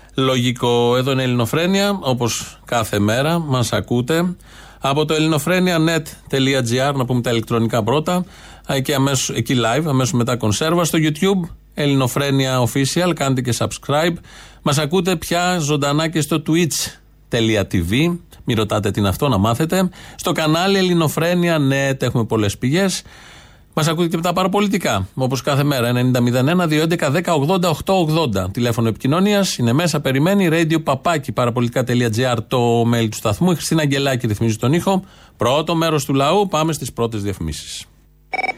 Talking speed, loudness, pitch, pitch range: 135 wpm, -18 LUFS, 140 Hz, 120-165 Hz